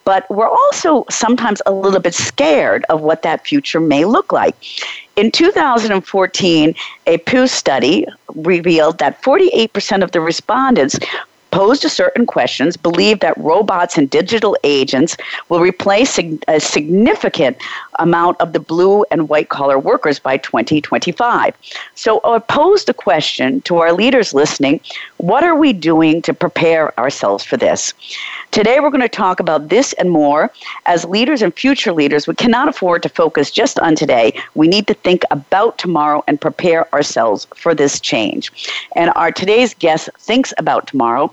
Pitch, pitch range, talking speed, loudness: 180 Hz, 160-230 Hz, 160 wpm, -13 LUFS